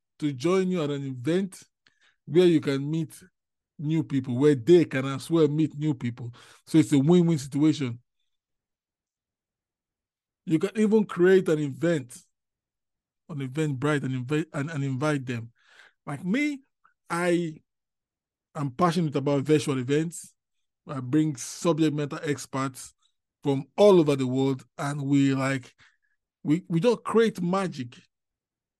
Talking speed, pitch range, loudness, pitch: 140 wpm, 130-165 Hz, -25 LUFS, 145 Hz